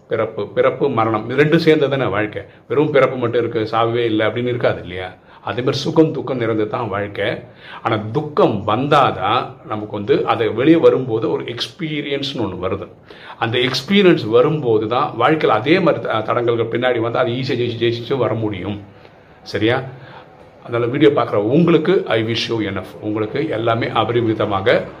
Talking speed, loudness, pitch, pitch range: 150 wpm, -17 LUFS, 120 Hz, 110-145 Hz